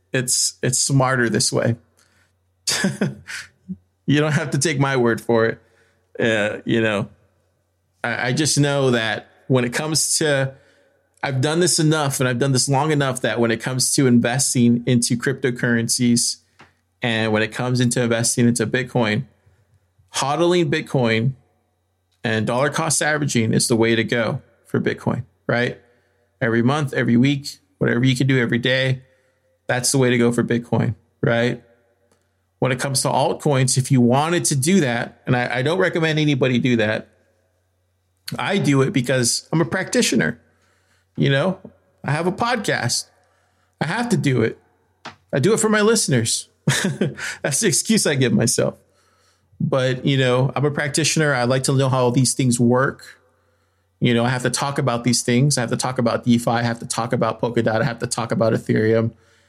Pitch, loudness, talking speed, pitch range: 125 Hz, -19 LUFS, 175 wpm, 115-140 Hz